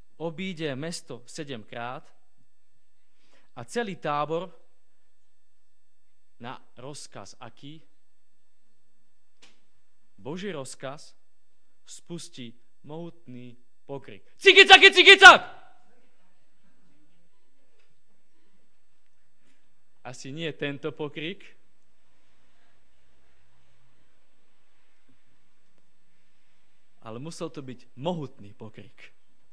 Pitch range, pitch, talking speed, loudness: 100-165 Hz, 130 Hz, 50 wpm, -17 LUFS